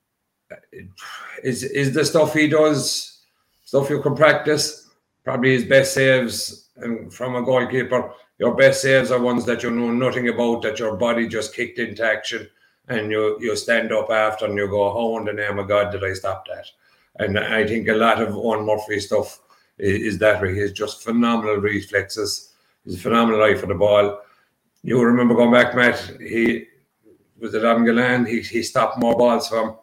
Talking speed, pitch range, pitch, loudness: 190 wpm, 105-125 Hz, 115 Hz, -19 LUFS